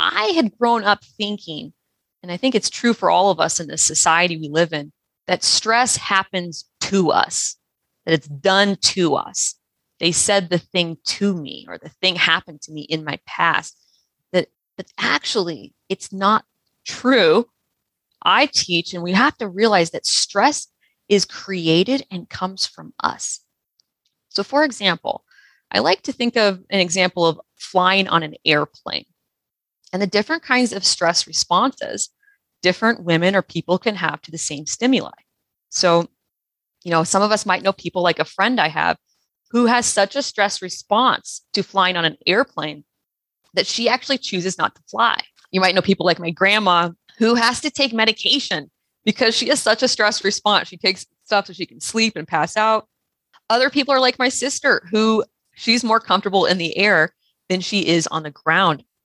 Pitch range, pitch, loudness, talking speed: 170-225 Hz, 195 Hz, -18 LUFS, 180 wpm